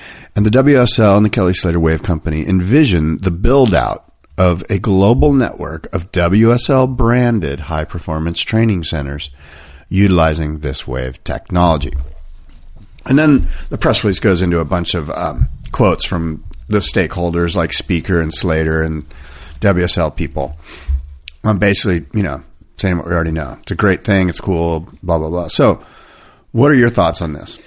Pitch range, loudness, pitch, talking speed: 80-100 Hz, -15 LUFS, 85 Hz, 165 wpm